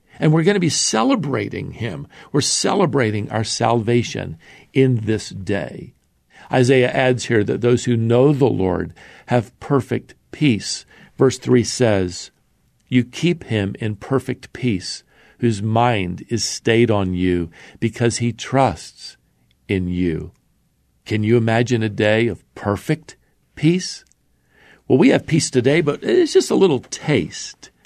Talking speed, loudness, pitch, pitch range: 140 wpm, -19 LUFS, 120 Hz, 105-135 Hz